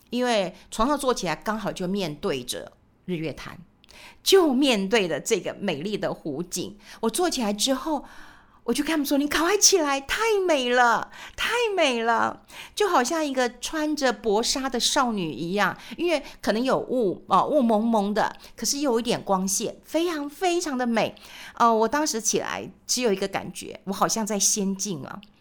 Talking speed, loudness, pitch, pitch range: 255 characters per minute, -24 LUFS, 235 Hz, 200-290 Hz